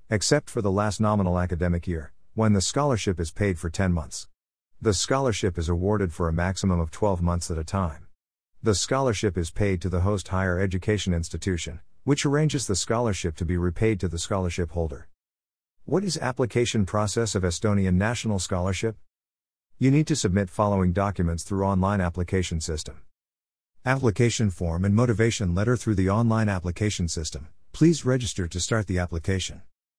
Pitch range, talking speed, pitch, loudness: 85-110 Hz, 165 wpm, 95 Hz, -25 LUFS